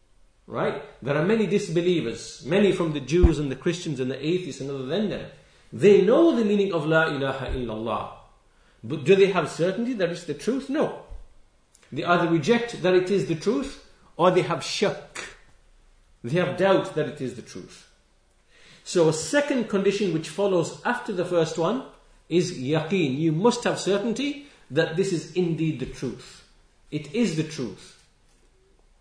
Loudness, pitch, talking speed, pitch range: -24 LUFS, 170 Hz, 170 wpm, 145-195 Hz